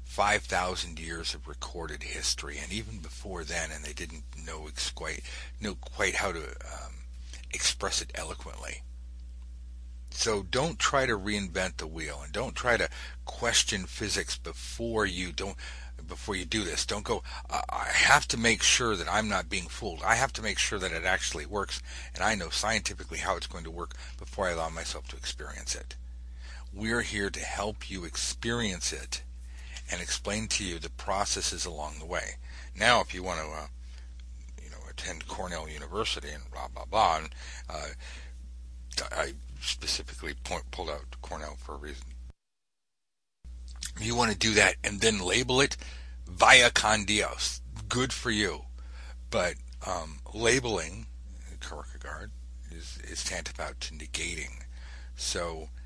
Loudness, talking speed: -29 LUFS, 160 wpm